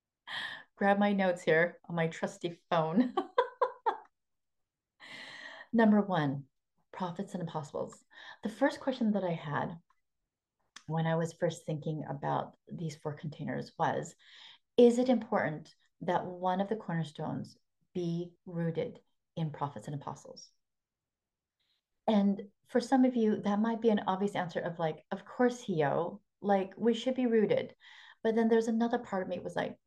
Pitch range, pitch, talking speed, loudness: 165-235 Hz, 195 Hz, 150 wpm, -32 LUFS